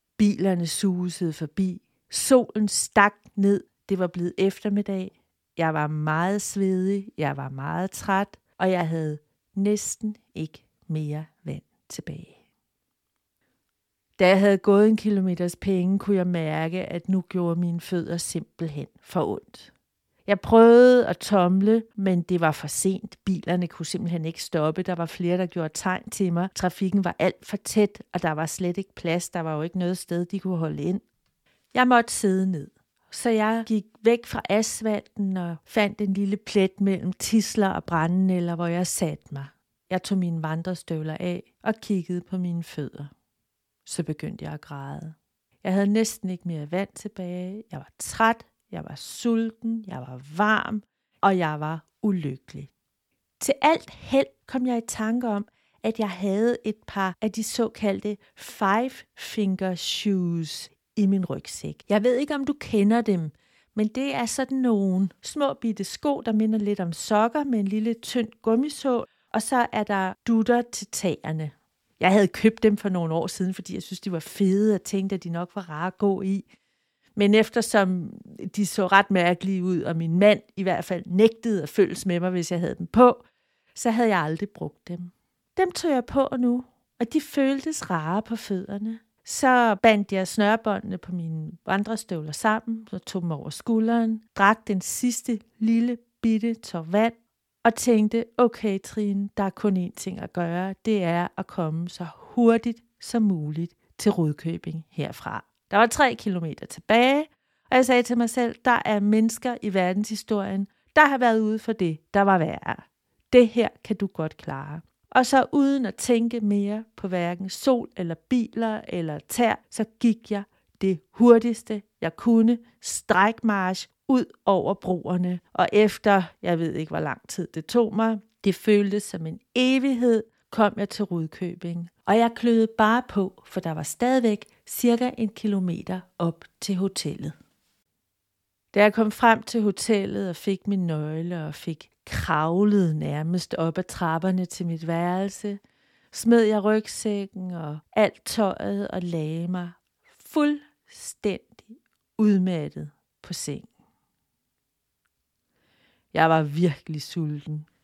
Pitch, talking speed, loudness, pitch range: 195 Hz, 165 wpm, -24 LUFS, 175-225 Hz